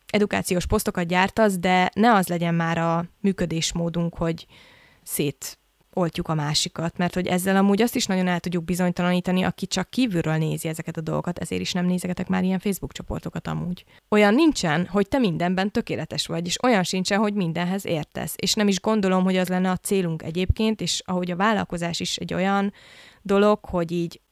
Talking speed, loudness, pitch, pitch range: 185 wpm, -23 LUFS, 180 Hz, 170-195 Hz